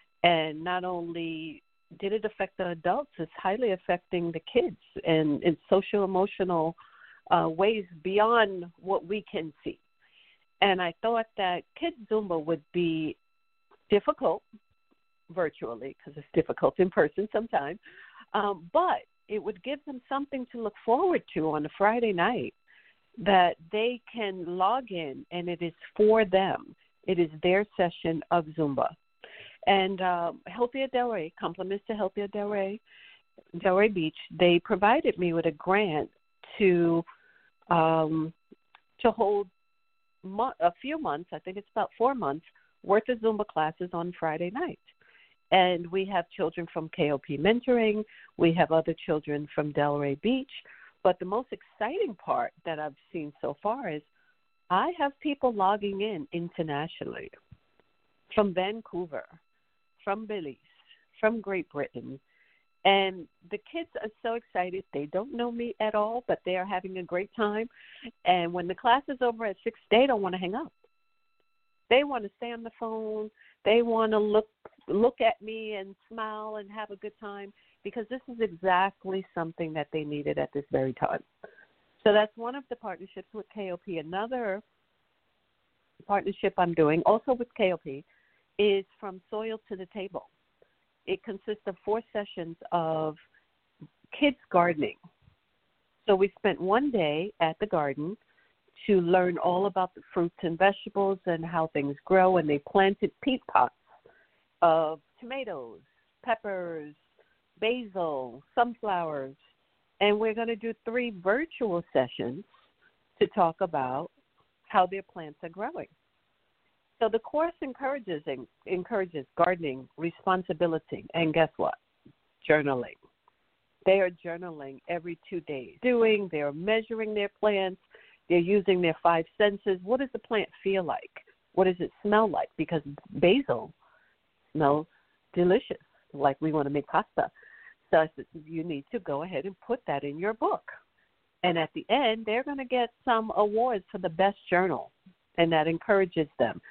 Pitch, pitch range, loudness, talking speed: 195 Hz, 170-225 Hz, -29 LUFS, 150 wpm